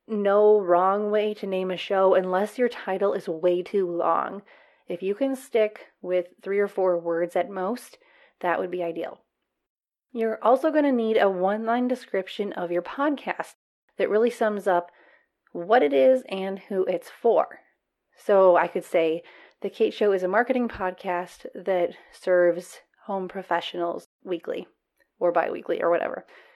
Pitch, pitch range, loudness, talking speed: 195 Hz, 180-220 Hz, -25 LUFS, 165 wpm